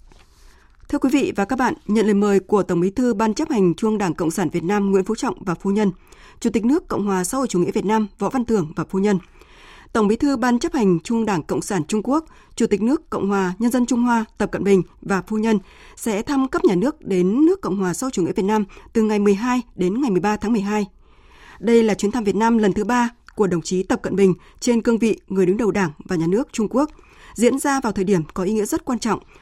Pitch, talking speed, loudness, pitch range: 210 Hz, 270 wpm, -20 LUFS, 195-245 Hz